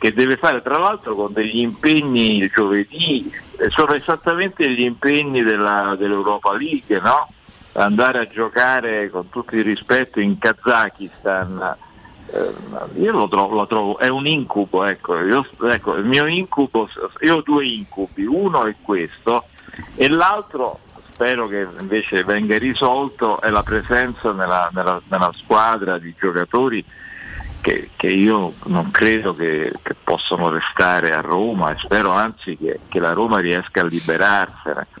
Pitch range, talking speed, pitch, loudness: 100-135 Hz, 145 wpm, 110 Hz, -18 LUFS